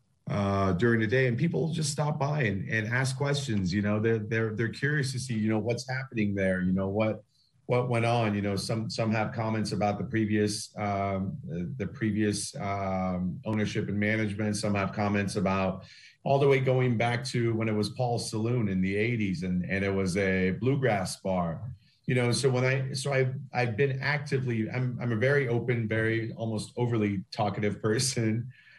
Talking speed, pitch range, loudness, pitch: 195 wpm, 105-125 Hz, -29 LUFS, 110 Hz